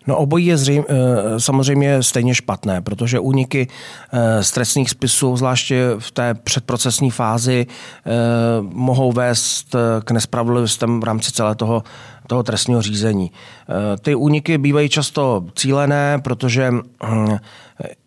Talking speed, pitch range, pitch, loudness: 115 wpm, 115-135 Hz, 125 Hz, -17 LUFS